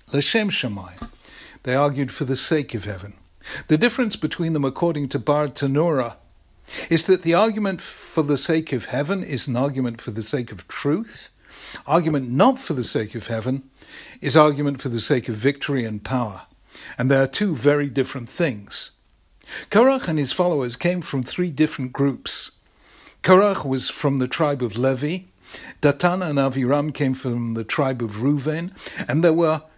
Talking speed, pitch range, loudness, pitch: 170 wpm, 125-160 Hz, -21 LUFS, 140 Hz